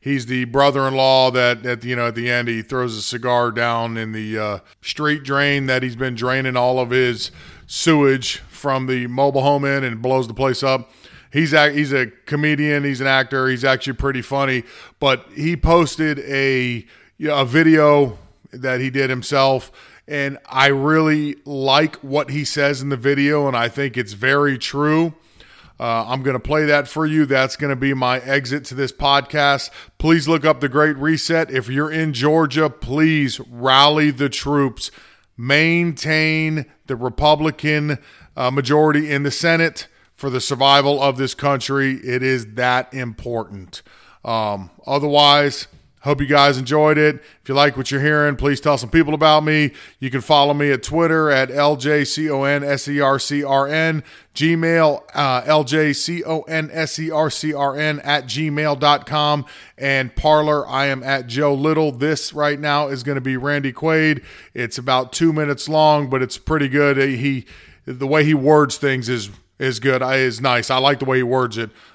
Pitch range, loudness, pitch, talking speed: 130-150 Hz, -18 LUFS, 140 Hz, 185 wpm